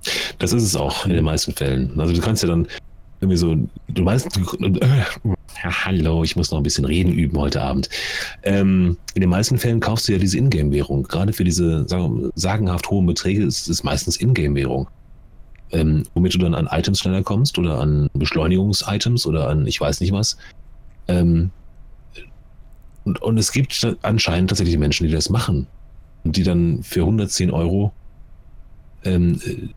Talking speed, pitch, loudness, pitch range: 165 wpm, 90 Hz, -19 LUFS, 80-100 Hz